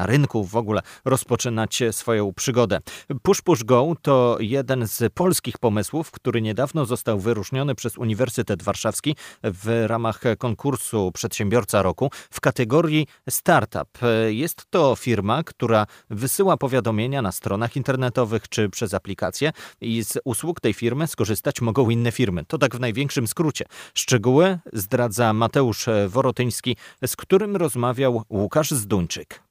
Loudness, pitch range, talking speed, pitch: -22 LUFS, 110-135 Hz, 130 wpm, 120 Hz